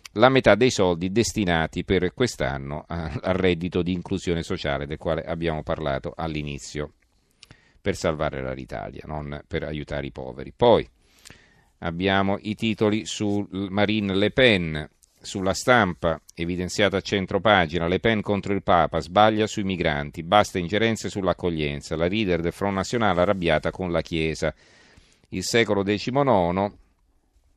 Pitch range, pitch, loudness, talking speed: 80-105 Hz, 90 Hz, -23 LUFS, 135 wpm